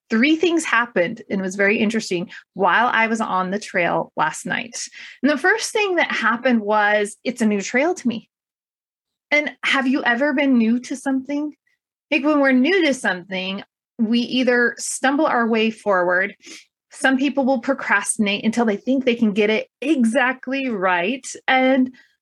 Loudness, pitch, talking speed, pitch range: -19 LUFS, 250 Hz, 170 wpm, 215-280 Hz